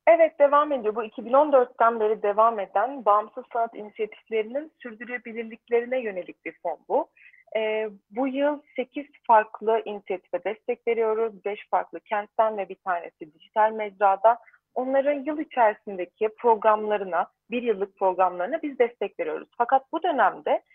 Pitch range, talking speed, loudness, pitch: 210-265 Hz, 130 wpm, -25 LUFS, 230 Hz